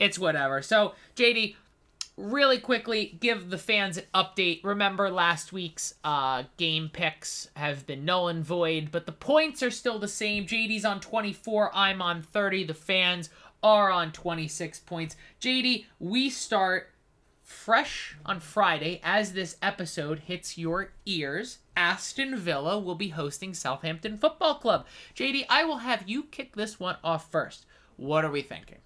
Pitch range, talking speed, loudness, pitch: 165-215 Hz, 155 wpm, -28 LUFS, 190 Hz